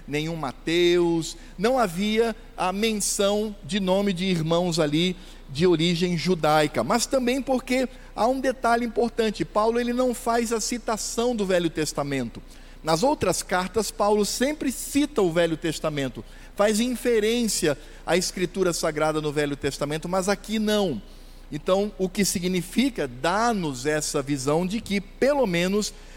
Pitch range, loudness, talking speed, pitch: 165-230 Hz, -24 LUFS, 140 wpm, 190 Hz